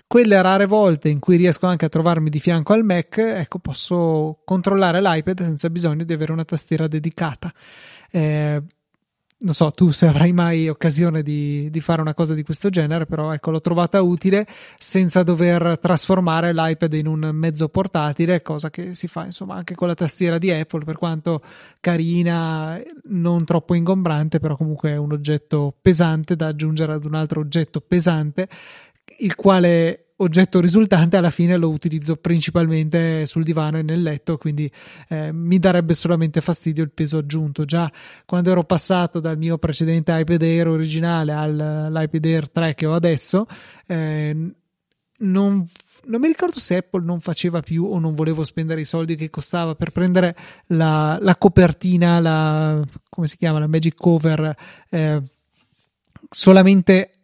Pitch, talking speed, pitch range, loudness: 165 Hz, 160 wpm, 155-180 Hz, -19 LUFS